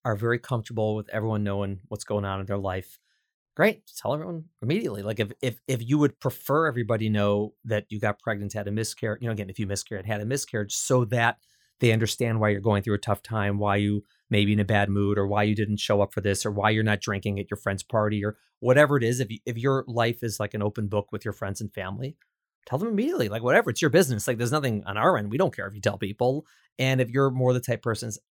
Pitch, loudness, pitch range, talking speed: 110 Hz, -26 LUFS, 105-120 Hz, 265 wpm